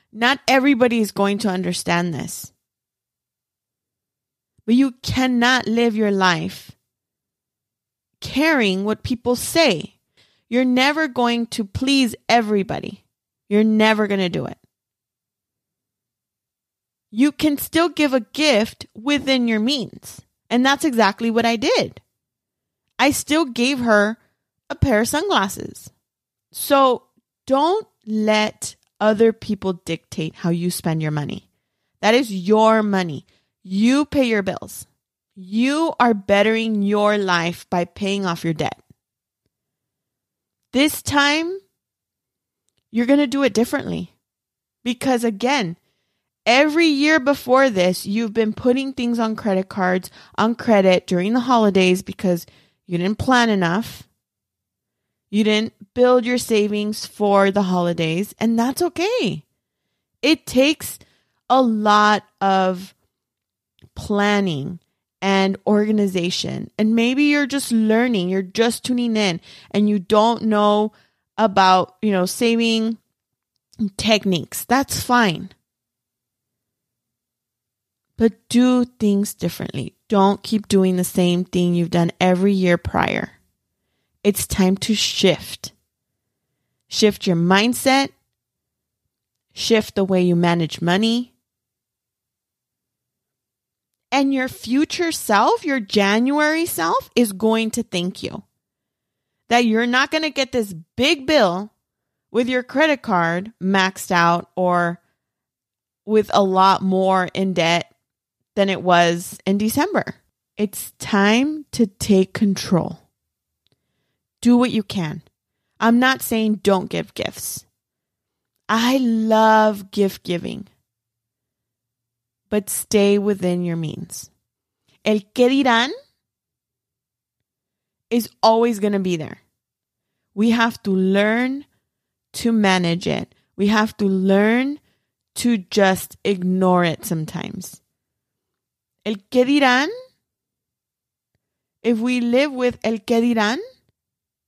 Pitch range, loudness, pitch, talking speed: 180-240 Hz, -19 LUFS, 210 Hz, 115 wpm